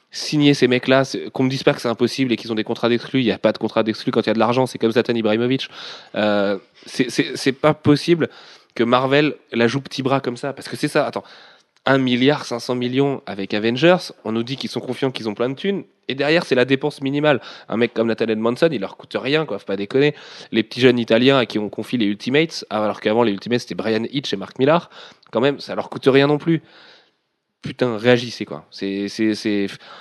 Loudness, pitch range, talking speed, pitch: -20 LUFS, 110-135 Hz, 245 wpm, 125 Hz